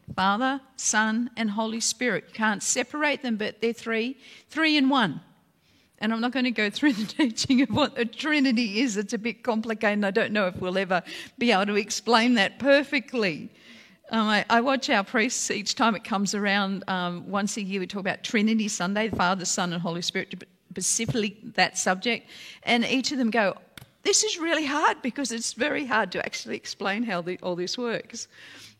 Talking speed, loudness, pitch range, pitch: 195 wpm, -25 LUFS, 200-250 Hz, 225 Hz